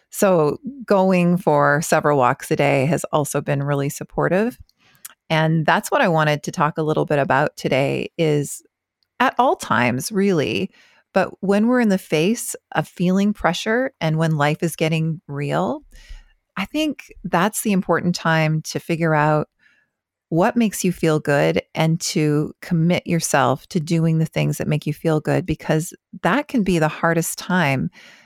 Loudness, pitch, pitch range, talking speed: -20 LUFS, 165 Hz, 150-190 Hz, 165 wpm